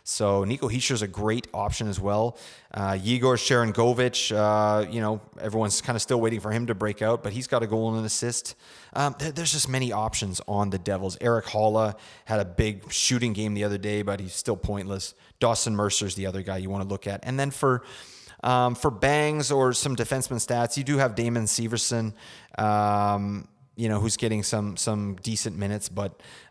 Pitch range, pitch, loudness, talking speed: 105-125 Hz, 110 Hz, -26 LUFS, 205 wpm